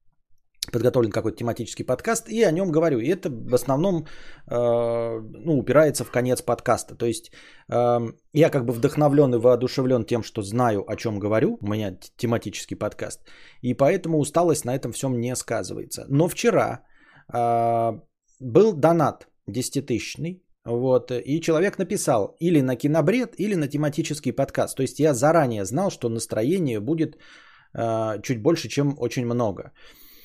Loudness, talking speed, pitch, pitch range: -23 LUFS, 155 wpm, 130 Hz, 120-155 Hz